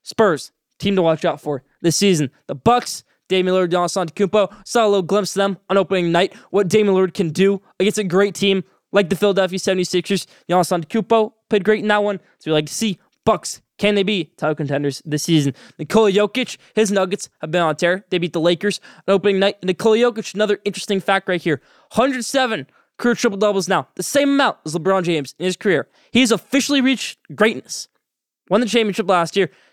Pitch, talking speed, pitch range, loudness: 195 Hz, 210 wpm, 175-215 Hz, -19 LUFS